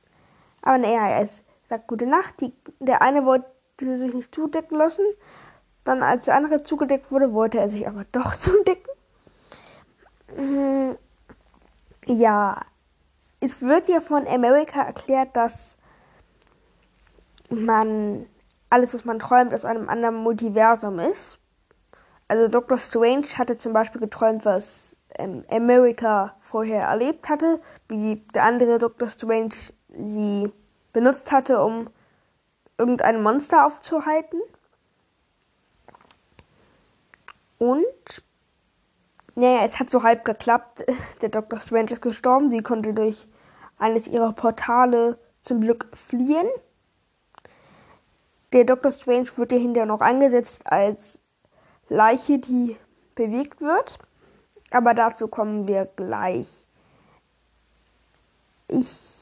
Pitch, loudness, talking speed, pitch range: 240 Hz, -21 LUFS, 110 wpm, 225-270 Hz